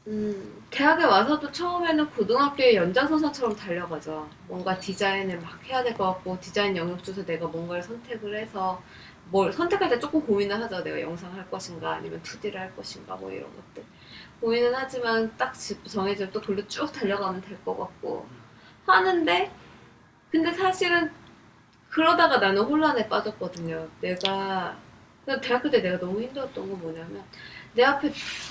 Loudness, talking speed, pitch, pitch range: -26 LUFS, 325 characters per minute, 205 Hz, 185-265 Hz